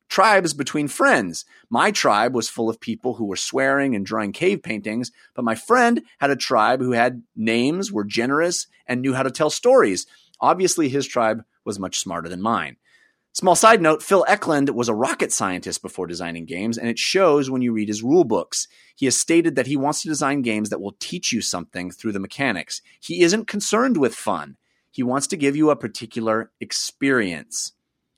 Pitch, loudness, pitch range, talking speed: 135 Hz, -21 LUFS, 115-165 Hz, 195 wpm